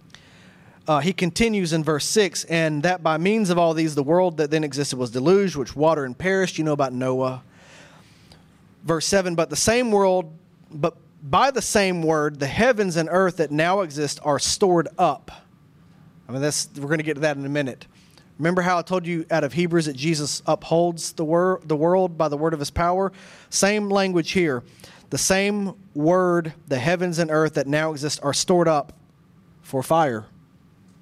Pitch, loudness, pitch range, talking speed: 165 Hz, -22 LUFS, 150-180 Hz, 195 wpm